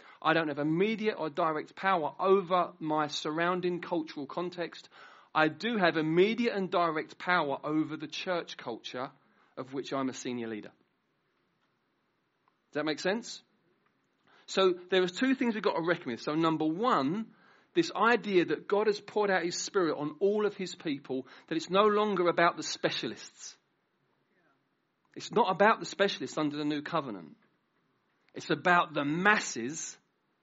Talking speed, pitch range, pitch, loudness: 160 wpm, 155-200 Hz, 175 Hz, -30 LUFS